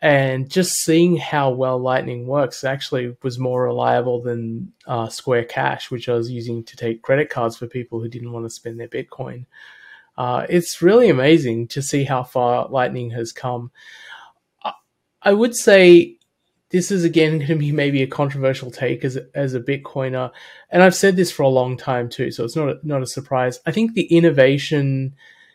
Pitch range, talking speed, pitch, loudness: 120-160 Hz, 195 wpm, 130 Hz, -18 LUFS